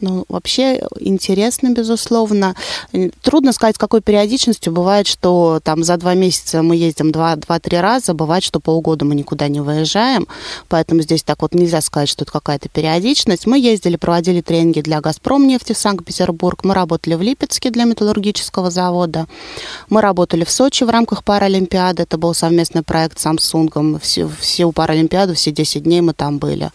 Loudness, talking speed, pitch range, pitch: -15 LUFS, 170 wpm, 160-210 Hz, 175 Hz